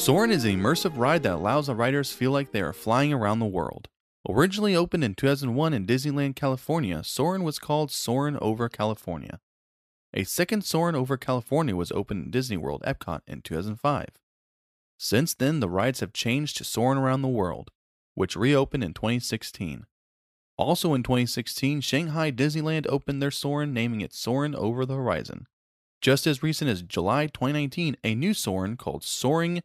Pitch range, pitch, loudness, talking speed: 110-150 Hz, 135 Hz, -26 LUFS, 170 wpm